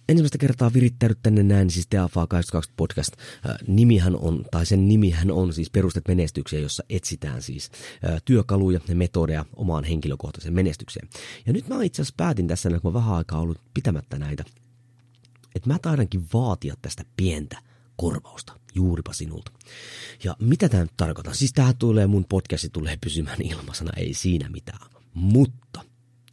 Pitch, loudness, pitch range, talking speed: 95 Hz, -23 LUFS, 85-120 Hz, 155 wpm